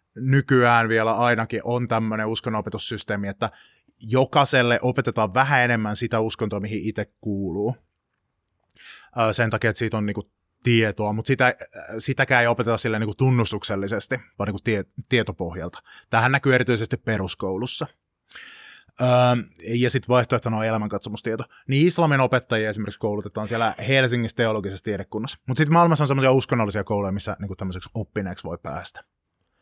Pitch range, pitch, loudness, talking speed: 105-125 Hz, 115 Hz, -22 LUFS, 130 wpm